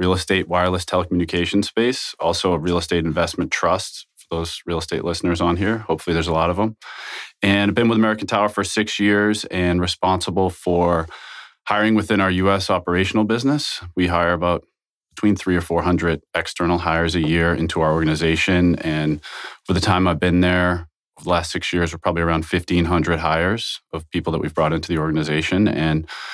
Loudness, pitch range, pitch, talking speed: -20 LUFS, 85-95 Hz, 90 Hz, 185 wpm